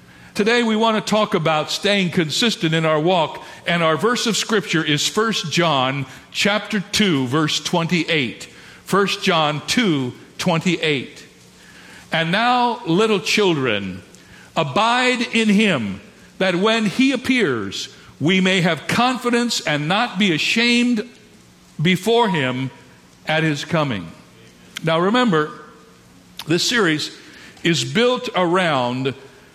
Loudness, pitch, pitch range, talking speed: -18 LUFS, 180 Hz, 155-220 Hz, 120 wpm